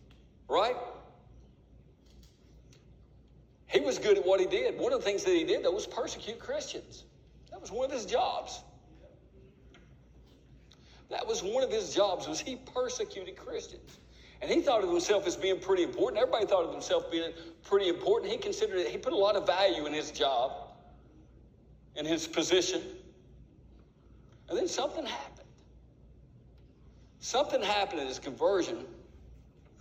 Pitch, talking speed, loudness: 395 Hz, 150 wpm, -31 LUFS